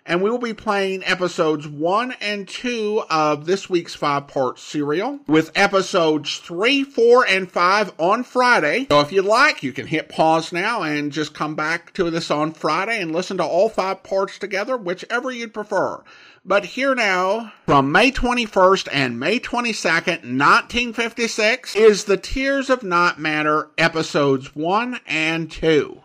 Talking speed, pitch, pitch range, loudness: 160 wpm, 185 Hz, 155-220 Hz, -19 LUFS